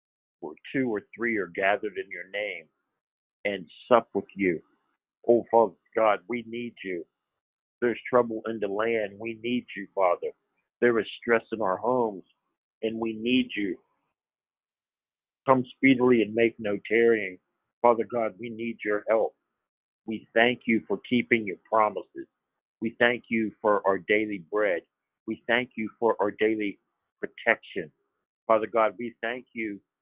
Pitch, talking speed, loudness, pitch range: 115 Hz, 150 wpm, -27 LUFS, 110-120 Hz